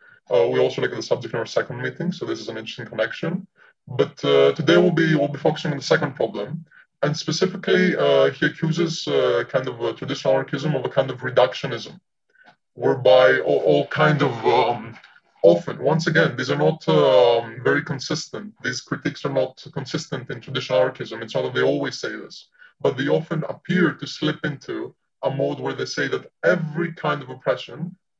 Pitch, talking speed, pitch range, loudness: 155 Hz, 195 wpm, 140-175 Hz, -21 LUFS